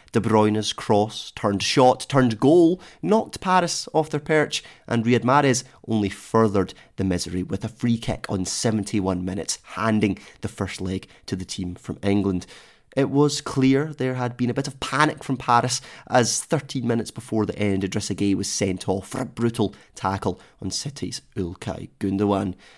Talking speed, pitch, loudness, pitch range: 175 wpm, 115 Hz, -23 LUFS, 100-130 Hz